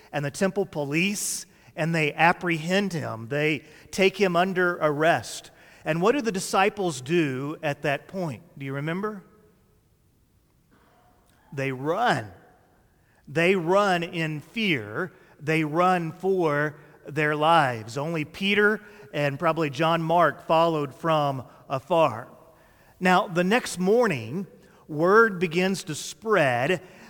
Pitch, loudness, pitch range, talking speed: 165 Hz, -24 LUFS, 150-185 Hz, 115 wpm